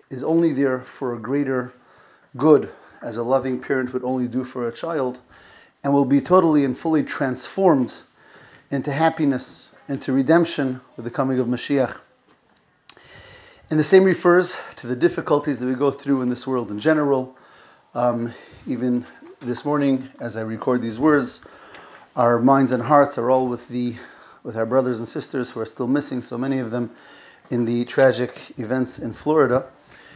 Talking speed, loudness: 170 wpm, -21 LUFS